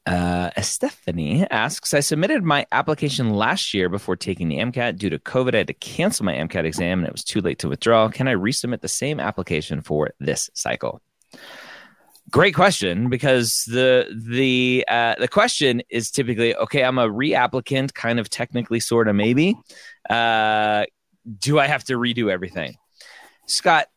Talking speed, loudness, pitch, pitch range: 170 wpm, -21 LUFS, 115 Hz, 105-130 Hz